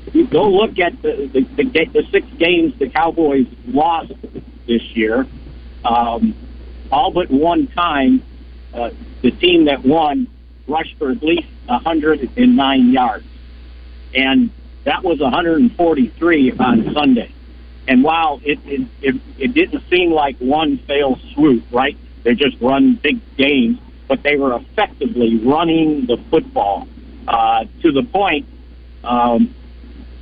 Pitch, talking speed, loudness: 140 Hz, 135 wpm, -16 LUFS